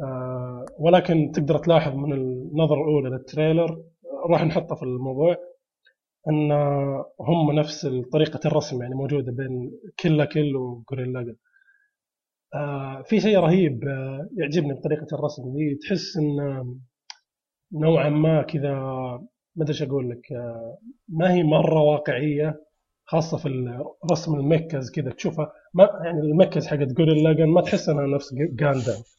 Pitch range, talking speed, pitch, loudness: 135-165 Hz, 125 wpm, 150 Hz, -23 LUFS